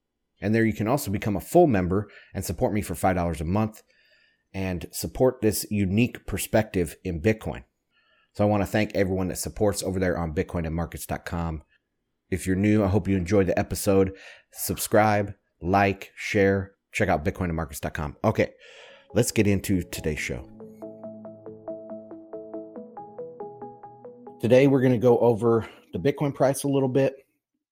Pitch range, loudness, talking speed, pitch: 90-110 Hz, -25 LUFS, 145 wpm, 105 Hz